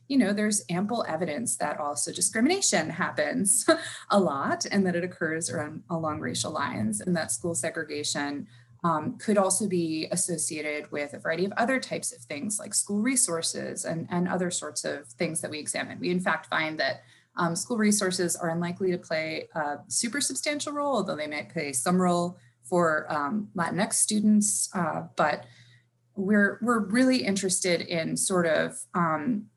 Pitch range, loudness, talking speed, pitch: 160-210 Hz, -27 LUFS, 170 wpm, 175 Hz